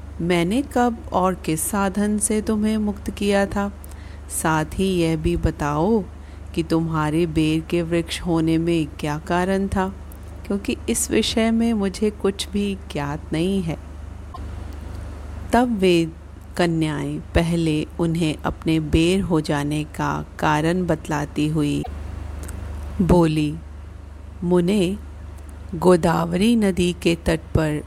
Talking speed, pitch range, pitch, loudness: 120 wpm, 145-190 Hz, 165 Hz, -21 LUFS